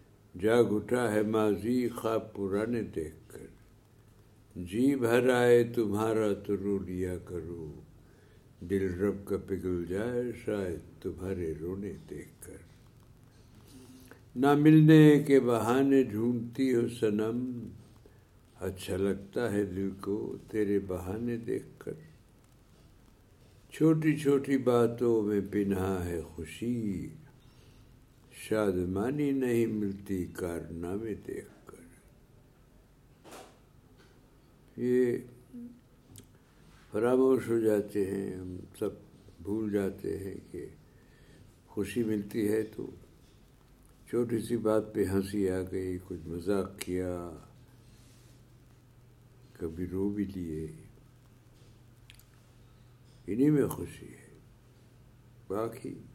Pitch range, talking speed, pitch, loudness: 100-120 Hz, 95 wpm, 110 Hz, -30 LUFS